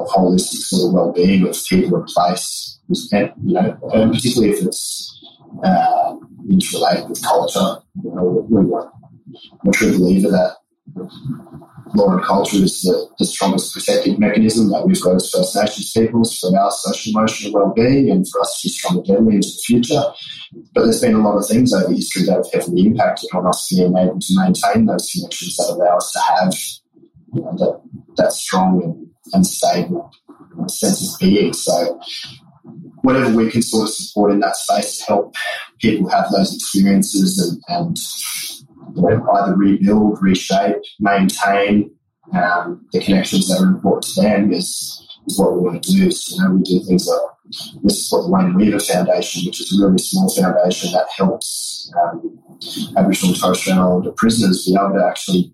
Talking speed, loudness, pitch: 185 wpm, -16 LUFS, 105 Hz